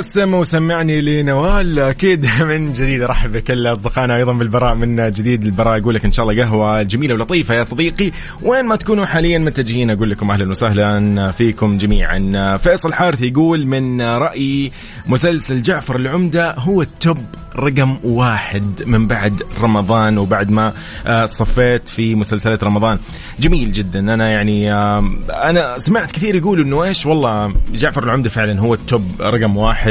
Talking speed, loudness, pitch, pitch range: 150 wpm, -15 LUFS, 120 Hz, 110-150 Hz